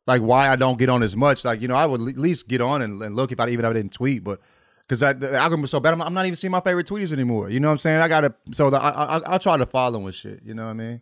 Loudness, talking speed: -21 LUFS, 345 wpm